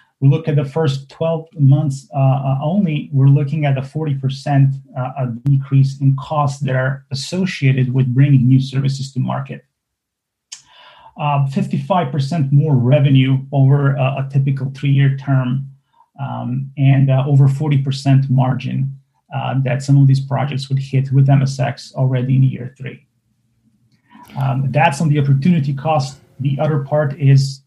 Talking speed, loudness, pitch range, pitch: 145 wpm, -16 LUFS, 130-145 Hz, 135 Hz